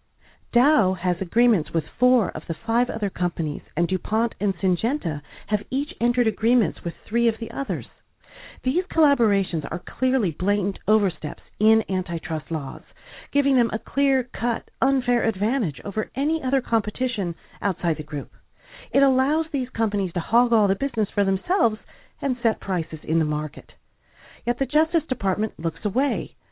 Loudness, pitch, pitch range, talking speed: -24 LUFS, 220 Hz, 180-250 Hz, 155 wpm